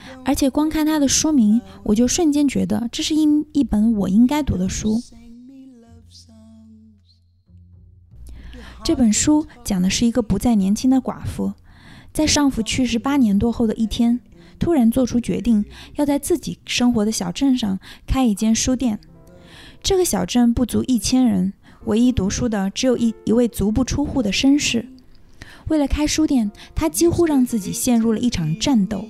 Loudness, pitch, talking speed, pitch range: -19 LUFS, 235 Hz, 240 characters per minute, 205-270 Hz